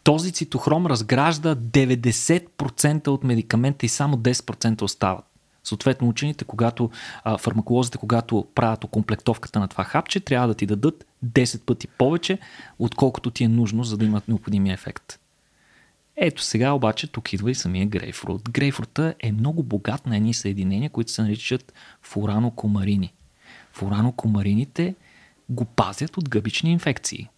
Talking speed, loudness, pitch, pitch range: 135 wpm, -23 LUFS, 120 Hz, 110-140 Hz